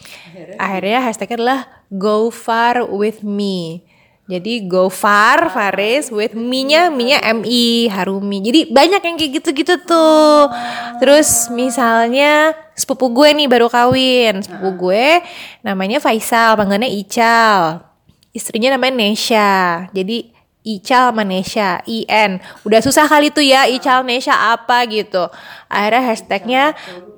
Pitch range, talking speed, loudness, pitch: 200-265 Hz, 120 wpm, -13 LUFS, 230 Hz